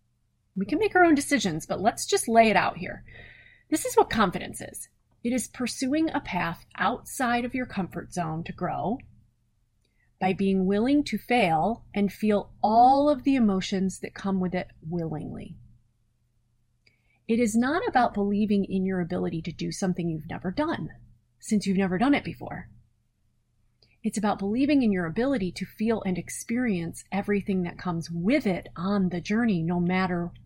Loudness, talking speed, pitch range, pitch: -26 LUFS, 170 wpm, 165-230 Hz, 190 Hz